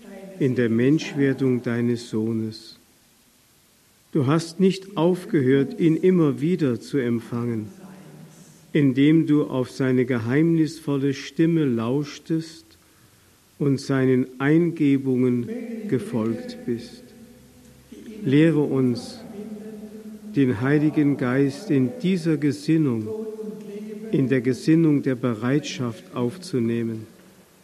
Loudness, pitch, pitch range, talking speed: -22 LUFS, 140 Hz, 125-165 Hz, 85 wpm